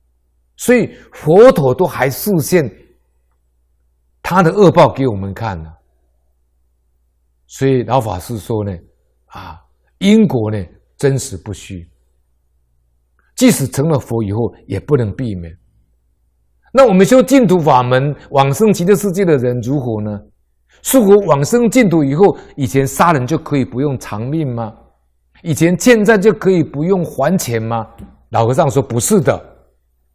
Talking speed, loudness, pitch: 205 characters per minute, -13 LUFS, 115 Hz